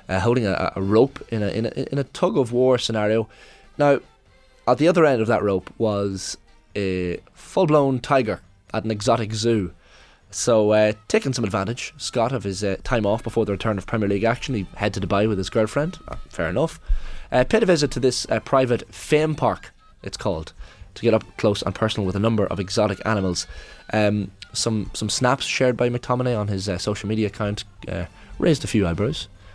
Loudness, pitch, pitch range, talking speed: -22 LUFS, 110 Hz, 100-125 Hz, 205 wpm